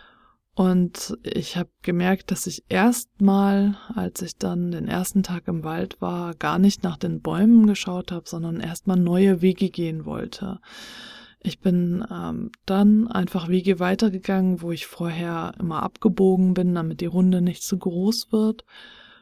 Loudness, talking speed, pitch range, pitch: -23 LUFS, 155 wpm, 175-200 Hz, 185 Hz